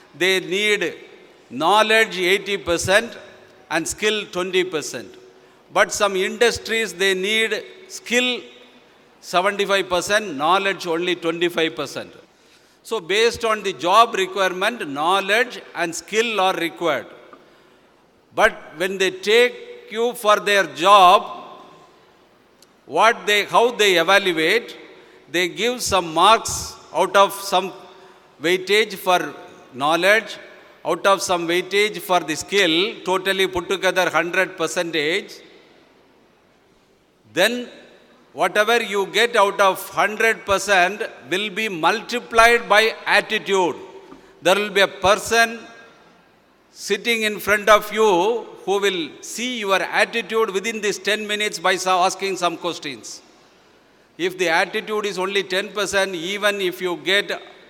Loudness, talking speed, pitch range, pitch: -19 LUFS, 115 wpm, 185-225 Hz, 200 Hz